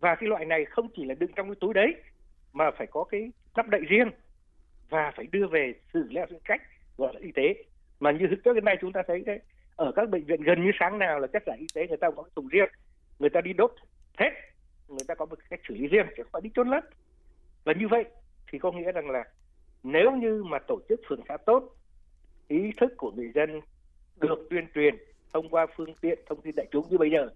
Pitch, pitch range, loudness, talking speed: 185 Hz, 155-230 Hz, -28 LUFS, 245 wpm